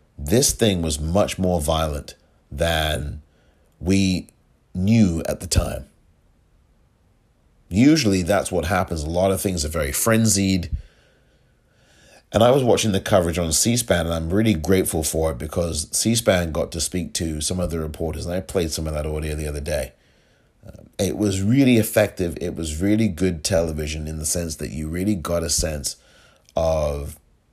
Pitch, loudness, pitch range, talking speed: 85 Hz, -21 LUFS, 80-95 Hz, 170 wpm